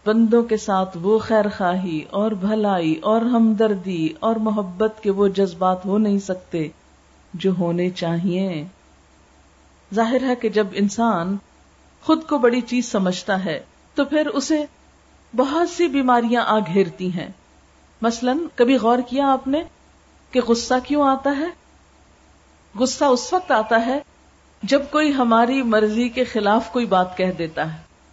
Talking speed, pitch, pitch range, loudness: 145 wpm, 215 Hz, 185-250 Hz, -20 LUFS